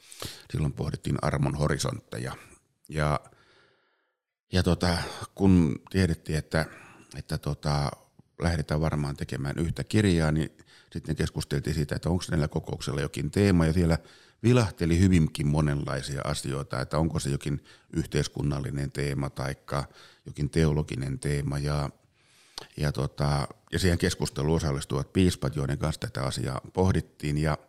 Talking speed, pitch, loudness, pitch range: 125 wpm, 75 Hz, -28 LUFS, 70-85 Hz